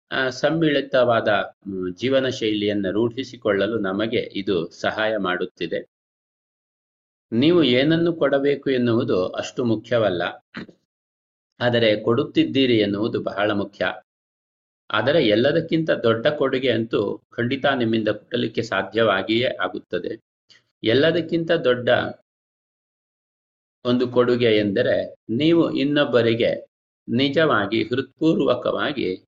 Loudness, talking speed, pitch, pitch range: -21 LUFS, 80 wpm, 120 Hz, 105-140 Hz